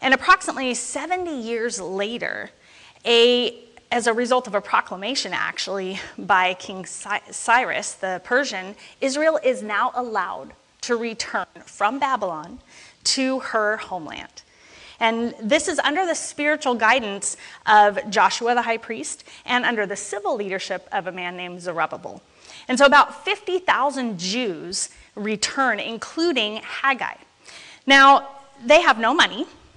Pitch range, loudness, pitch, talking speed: 205-275 Hz, -21 LUFS, 240 Hz, 130 wpm